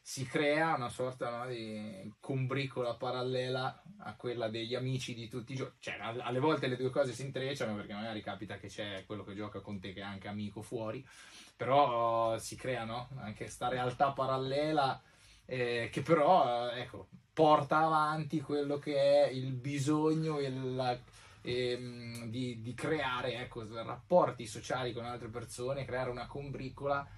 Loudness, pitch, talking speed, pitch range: -35 LUFS, 125 Hz, 165 wpm, 115-140 Hz